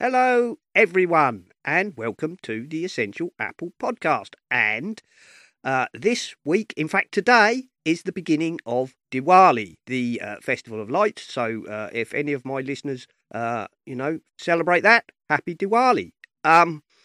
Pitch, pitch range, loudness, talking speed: 165 Hz, 130-195 Hz, -22 LUFS, 145 wpm